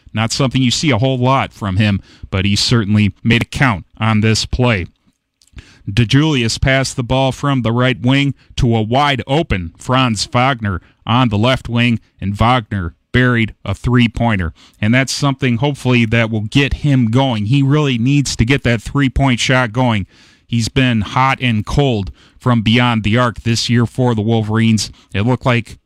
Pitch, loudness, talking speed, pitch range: 120 Hz, -15 LUFS, 180 wpm, 110-130 Hz